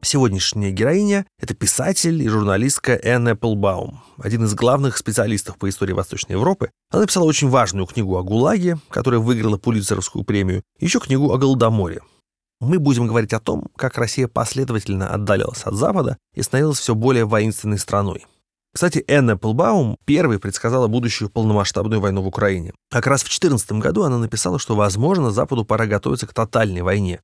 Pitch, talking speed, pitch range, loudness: 115 Hz, 165 wpm, 105-135 Hz, -19 LUFS